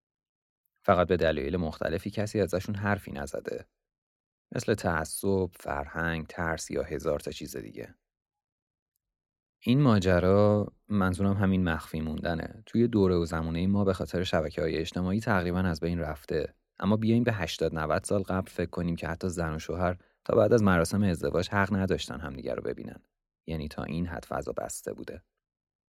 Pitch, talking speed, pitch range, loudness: 90 Hz, 155 wpm, 80-100 Hz, -29 LUFS